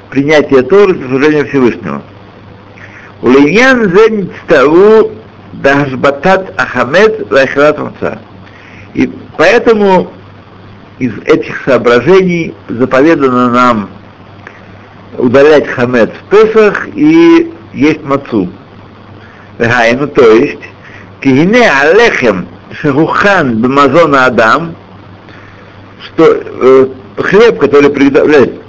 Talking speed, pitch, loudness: 85 wpm, 135 Hz, -7 LUFS